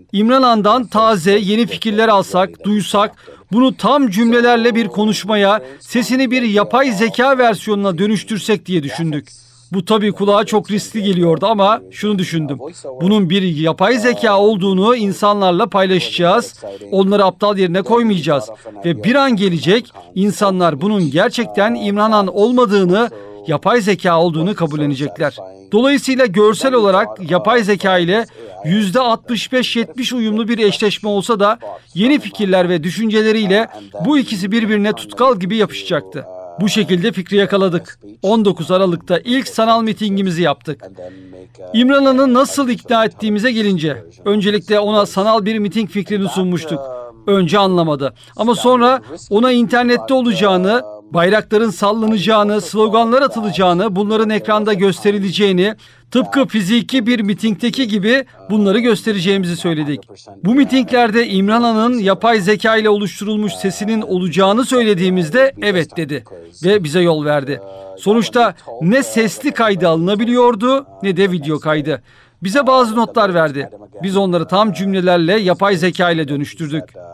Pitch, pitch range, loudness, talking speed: 205 Hz, 180-225 Hz, -14 LUFS, 120 wpm